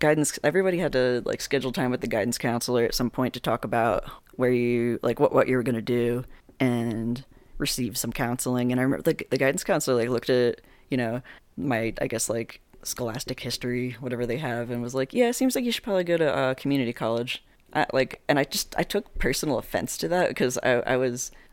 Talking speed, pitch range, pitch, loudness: 230 wpm, 120-135 Hz, 125 Hz, -26 LUFS